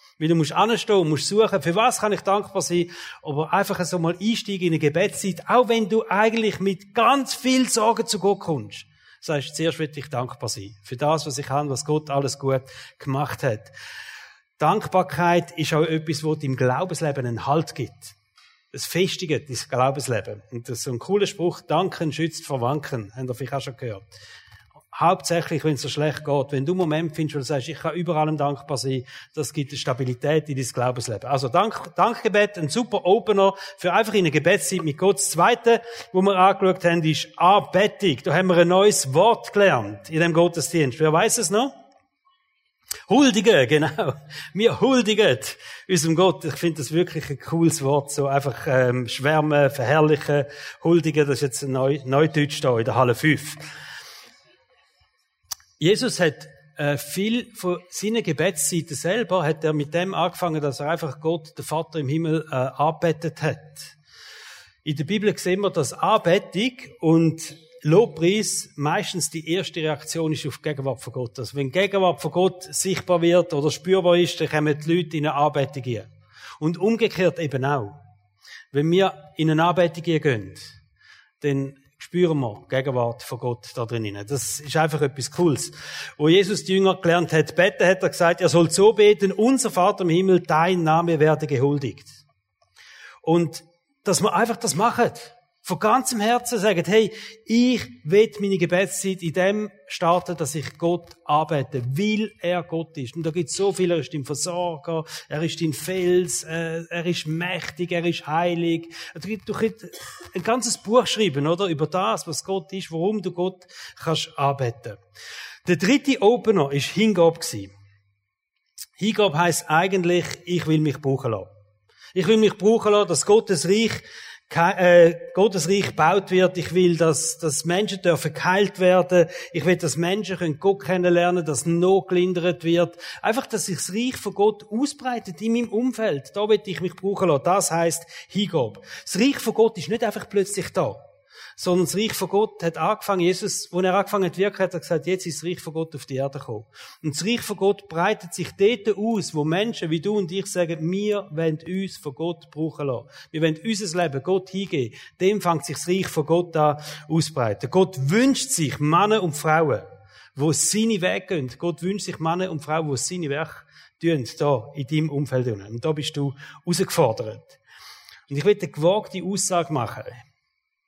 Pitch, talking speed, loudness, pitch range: 170 Hz, 180 wpm, -22 LUFS, 145-190 Hz